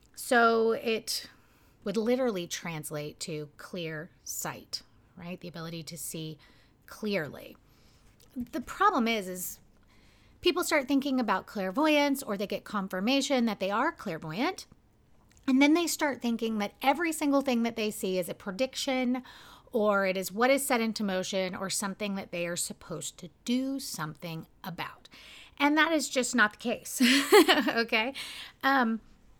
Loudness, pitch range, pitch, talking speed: -29 LUFS, 180-265 Hz, 220 Hz, 150 wpm